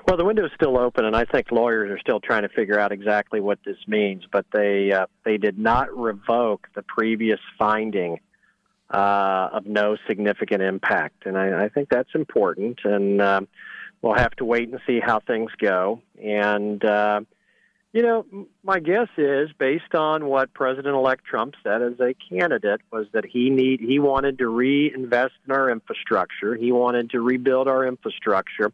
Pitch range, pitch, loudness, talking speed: 105-130 Hz, 120 Hz, -22 LUFS, 180 wpm